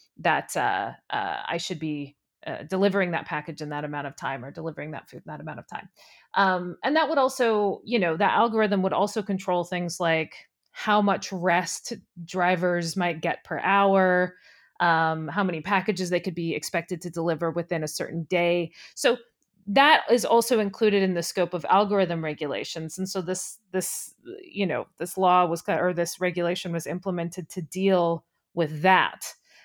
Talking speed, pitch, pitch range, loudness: 180 wpm, 180 Hz, 170-195 Hz, -25 LUFS